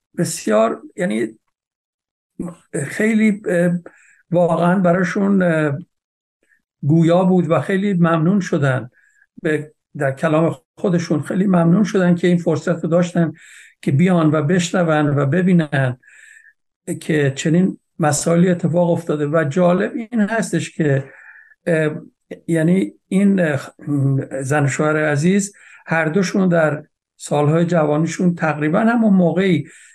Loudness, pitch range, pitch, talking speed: -17 LUFS, 155-185 Hz, 170 Hz, 100 wpm